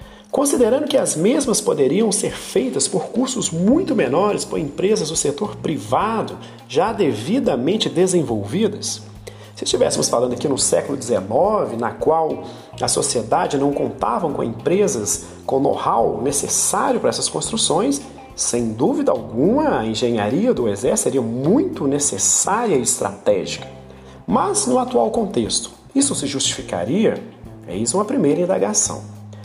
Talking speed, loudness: 130 wpm, -19 LUFS